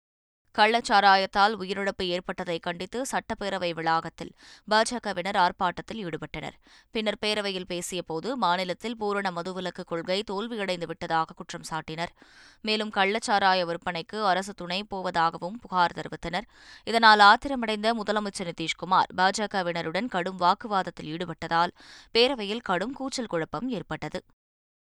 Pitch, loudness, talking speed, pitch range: 185 Hz, -26 LUFS, 100 wpm, 175-210 Hz